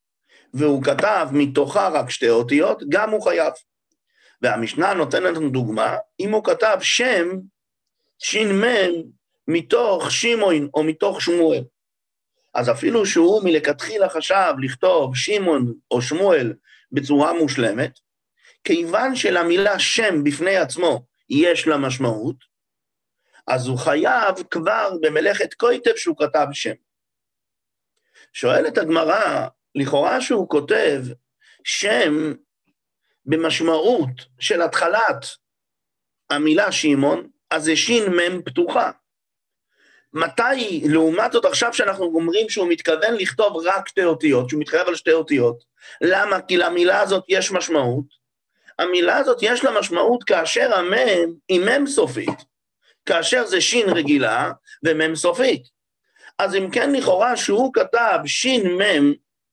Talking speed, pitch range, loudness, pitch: 115 wpm, 150-225 Hz, -19 LUFS, 175 Hz